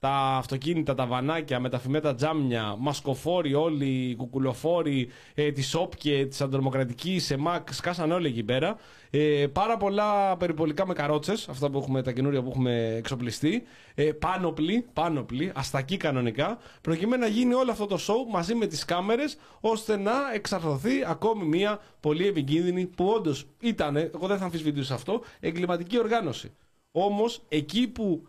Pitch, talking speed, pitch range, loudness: 155 Hz, 150 wpm, 135-195 Hz, -28 LUFS